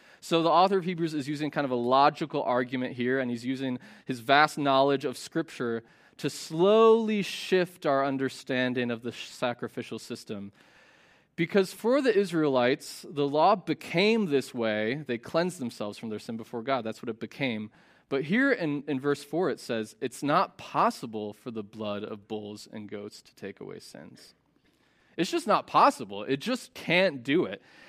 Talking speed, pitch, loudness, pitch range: 175 wpm, 135 Hz, -28 LUFS, 120-165 Hz